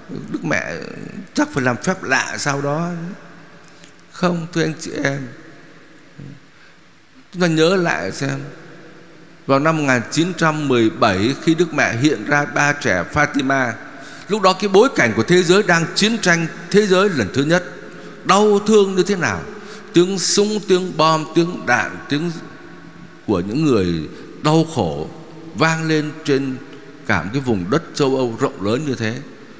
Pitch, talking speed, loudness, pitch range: 160 Hz, 155 wpm, -17 LUFS, 140-180 Hz